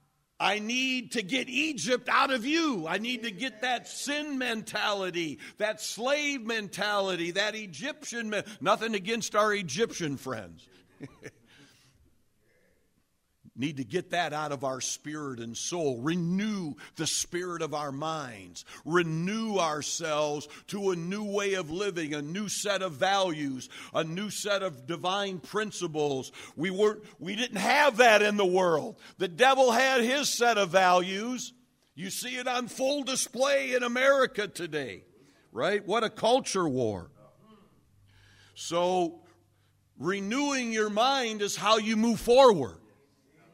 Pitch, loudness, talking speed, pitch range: 195 Hz, -28 LUFS, 140 wpm, 155-230 Hz